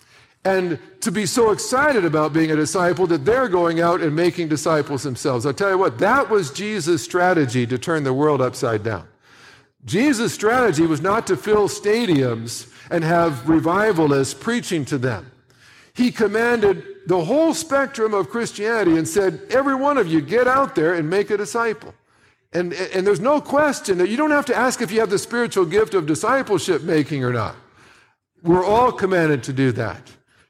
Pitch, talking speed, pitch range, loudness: 180 Hz, 180 wpm, 150-220 Hz, -19 LUFS